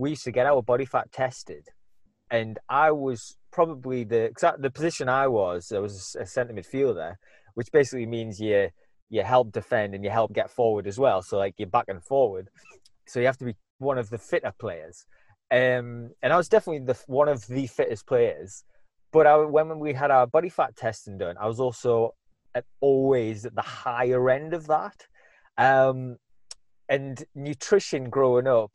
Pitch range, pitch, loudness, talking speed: 115-145 Hz, 125 Hz, -25 LUFS, 190 wpm